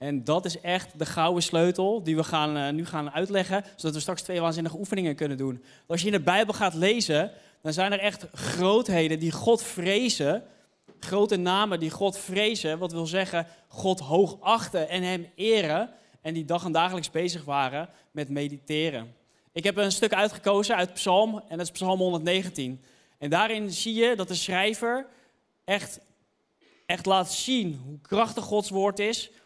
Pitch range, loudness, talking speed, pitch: 160-205 Hz, -27 LUFS, 175 wpm, 180 Hz